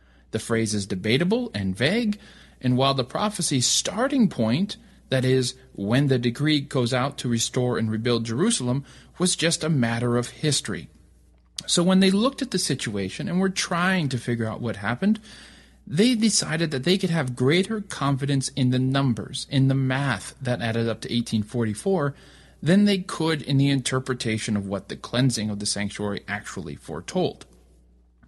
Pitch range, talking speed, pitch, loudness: 115-160 Hz, 170 wpm, 130 Hz, -24 LUFS